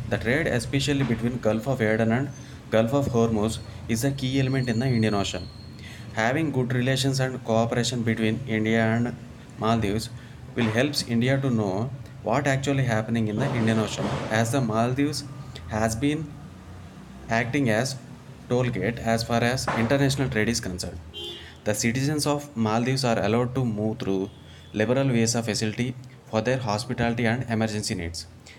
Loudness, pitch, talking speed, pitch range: -25 LUFS, 115 Hz, 155 wpm, 110-130 Hz